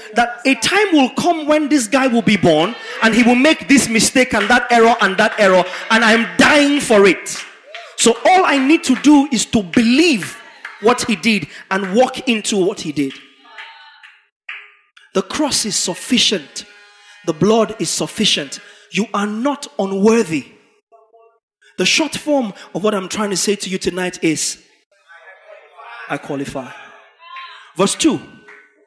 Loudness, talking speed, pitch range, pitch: -15 LUFS, 155 wpm, 195-260 Hz, 225 Hz